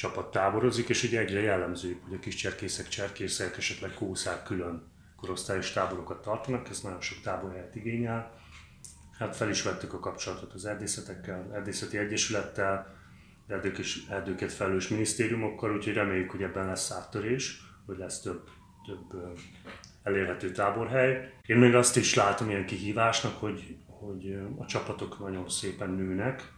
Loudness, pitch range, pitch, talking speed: -31 LUFS, 95-110 Hz, 100 Hz, 140 wpm